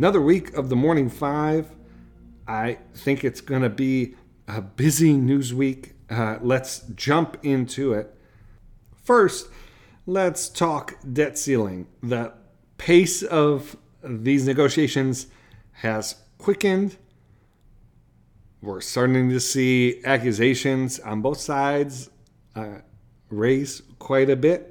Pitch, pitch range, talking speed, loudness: 130 Hz, 115-145 Hz, 110 wpm, -22 LUFS